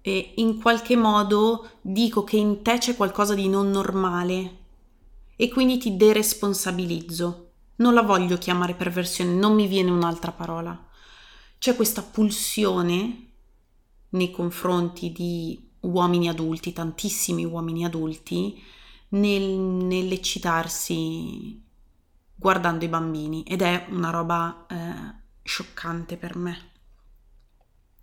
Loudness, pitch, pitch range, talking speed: -24 LUFS, 180 Hz, 170-205 Hz, 110 wpm